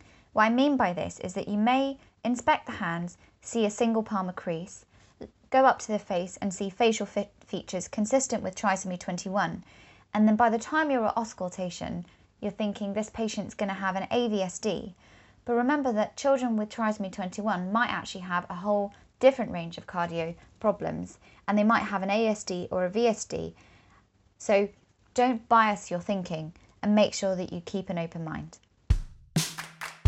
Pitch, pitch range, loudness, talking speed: 205 Hz, 185-225 Hz, -28 LUFS, 175 wpm